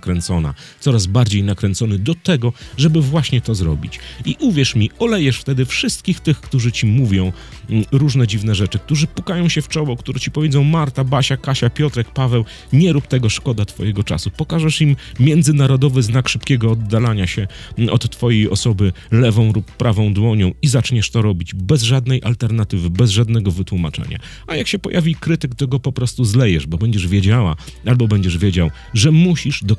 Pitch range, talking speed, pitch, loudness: 105-140 Hz, 170 wpm, 120 Hz, -16 LUFS